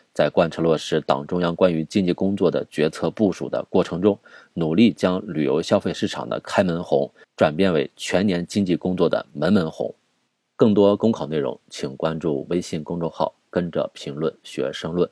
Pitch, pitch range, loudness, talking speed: 90 Hz, 80-95 Hz, -22 LUFS, 280 characters per minute